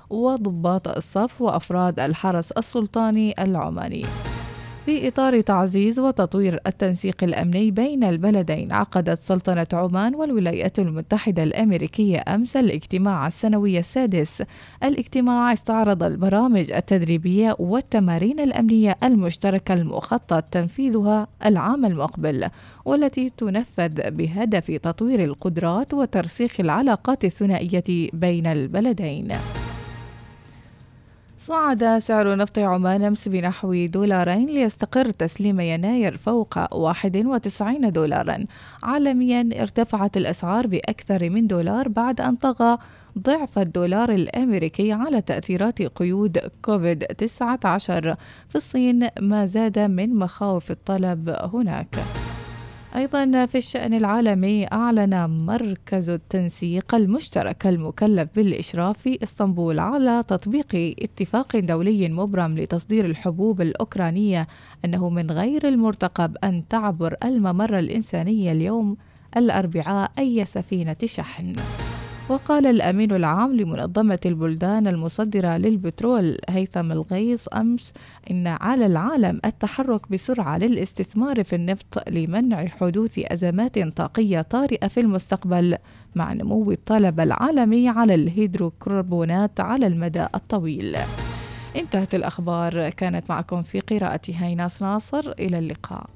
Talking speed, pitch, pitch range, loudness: 100 wpm, 195 Hz, 175-225 Hz, -22 LUFS